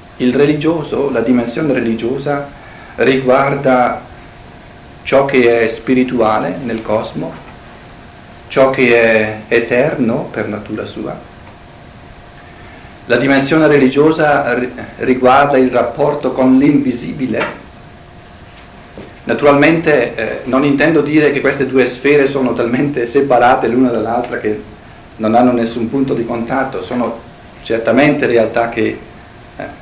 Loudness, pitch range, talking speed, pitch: -13 LUFS, 115-140 Hz, 105 wpm, 130 Hz